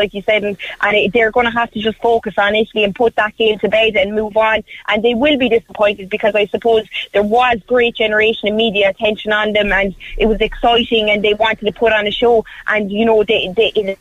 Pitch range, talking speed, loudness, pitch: 210-225 Hz, 255 wpm, -14 LUFS, 215 Hz